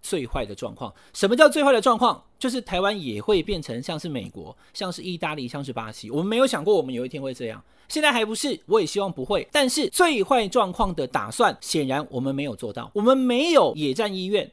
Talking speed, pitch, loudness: 345 characters per minute, 205 Hz, -23 LUFS